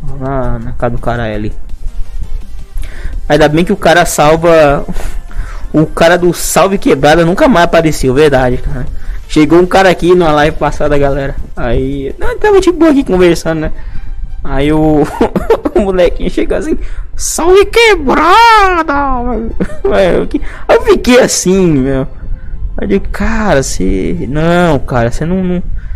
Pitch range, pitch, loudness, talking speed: 125-190 Hz, 155 Hz, -10 LUFS, 135 wpm